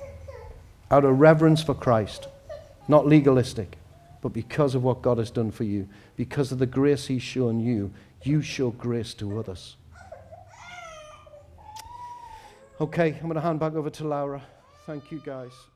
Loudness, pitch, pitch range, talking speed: -24 LUFS, 130 Hz, 115-155 Hz, 150 wpm